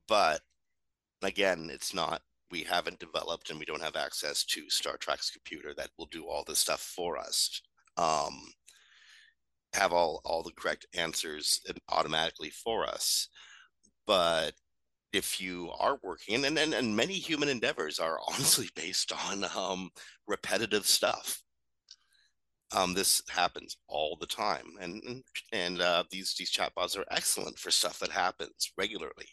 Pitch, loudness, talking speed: 105 Hz, -31 LUFS, 145 wpm